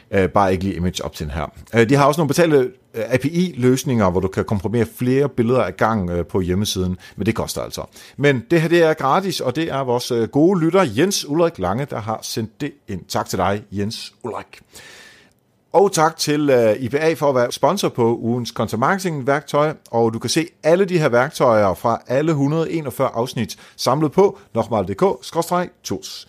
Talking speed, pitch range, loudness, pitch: 185 wpm, 110-160 Hz, -19 LUFS, 125 Hz